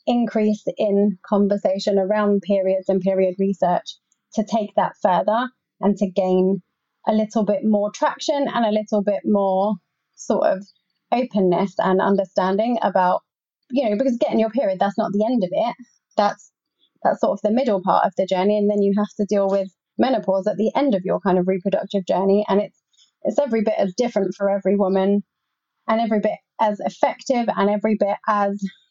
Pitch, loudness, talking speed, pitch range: 205 Hz, -21 LUFS, 185 wpm, 195-225 Hz